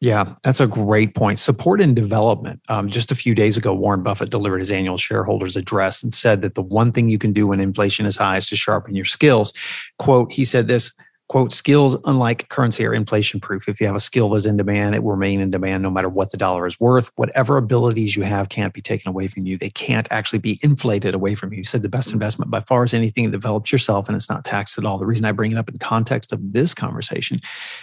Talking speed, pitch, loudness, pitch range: 250 wpm, 110 Hz, -18 LUFS, 100-120 Hz